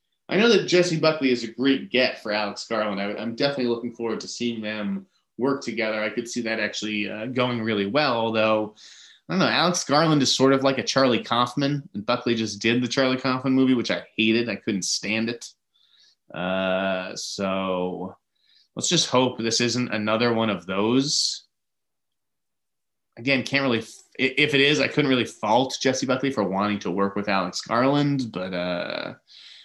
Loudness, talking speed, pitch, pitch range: -23 LUFS, 185 wpm, 115 Hz, 105-135 Hz